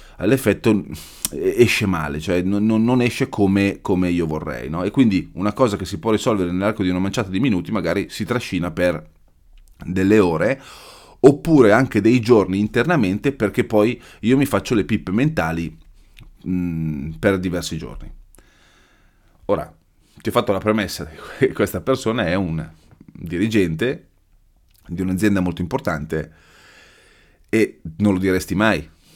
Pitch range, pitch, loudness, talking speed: 90-110 Hz, 95 Hz, -19 LUFS, 145 wpm